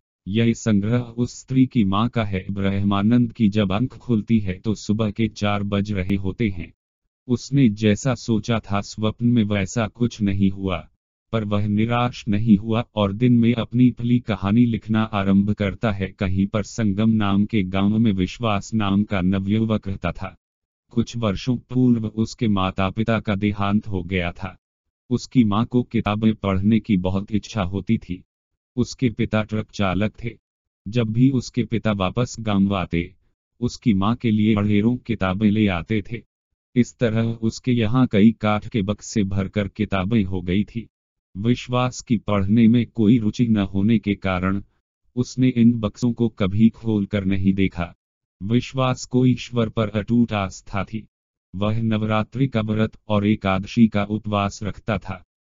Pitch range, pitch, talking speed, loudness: 100-115 Hz, 105 Hz, 165 wpm, -21 LUFS